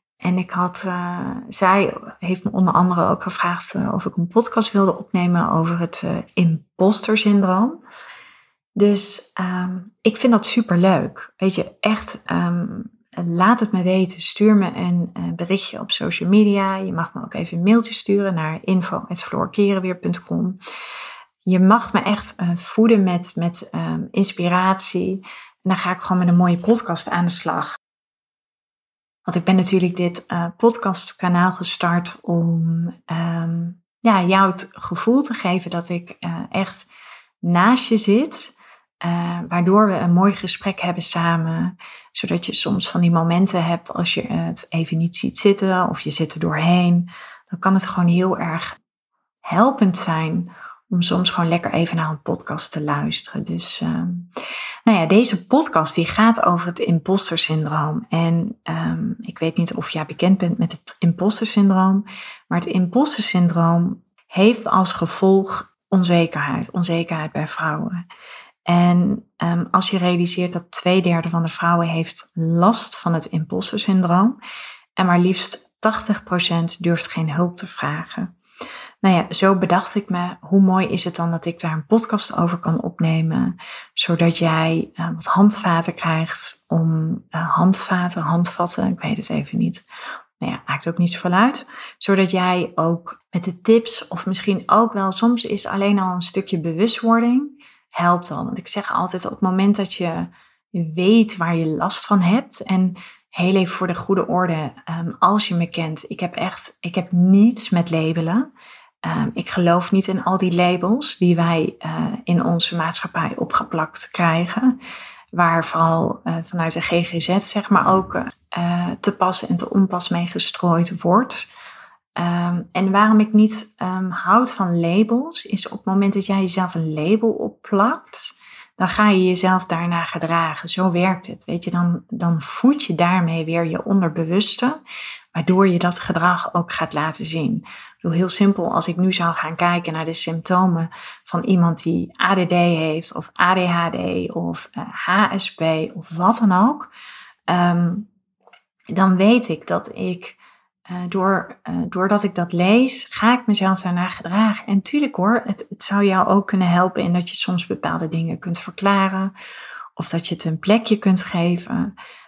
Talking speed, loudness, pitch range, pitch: 165 wpm, -19 LUFS, 170-200 Hz, 180 Hz